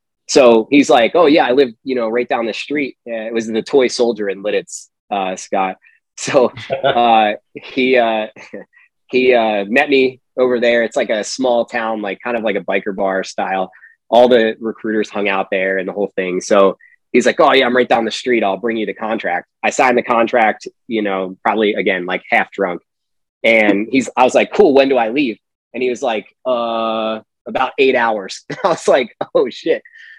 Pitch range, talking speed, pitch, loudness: 105-130 Hz, 205 wpm, 115 Hz, -15 LUFS